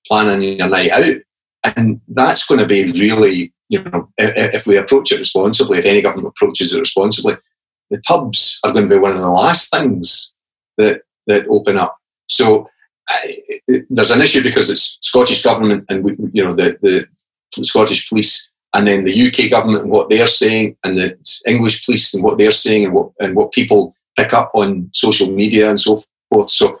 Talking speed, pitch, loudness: 190 wpm, 110 Hz, -13 LUFS